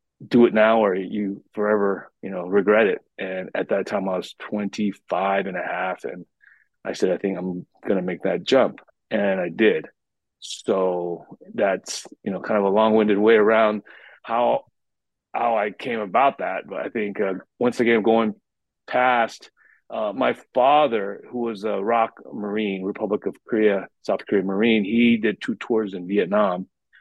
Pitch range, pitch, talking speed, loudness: 100-110 Hz, 105 Hz, 170 wpm, -22 LUFS